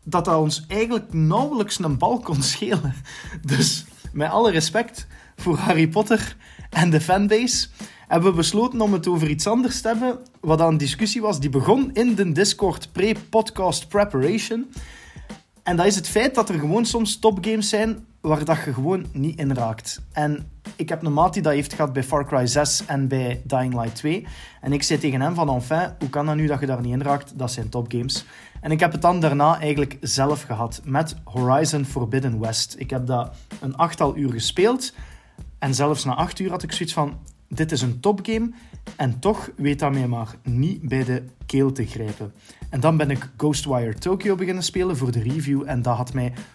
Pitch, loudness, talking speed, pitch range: 155 Hz, -22 LUFS, 205 wpm, 135-195 Hz